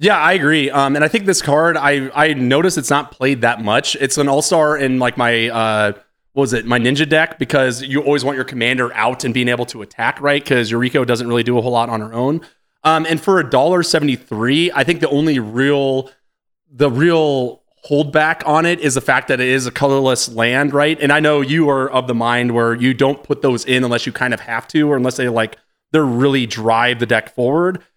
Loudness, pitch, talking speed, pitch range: -15 LUFS, 135 Hz, 230 wpm, 120-150 Hz